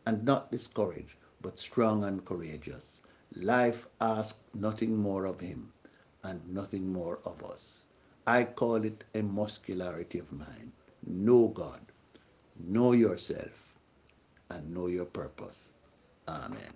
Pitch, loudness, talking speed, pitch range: 100 Hz, -32 LUFS, 120 wpm, 90-110 Hz